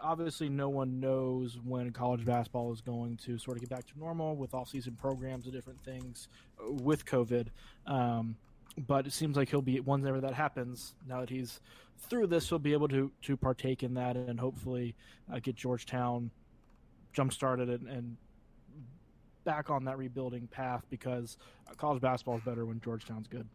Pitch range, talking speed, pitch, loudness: 120-135 Hz, 180 wpm, 130 Hz, -36 LUFS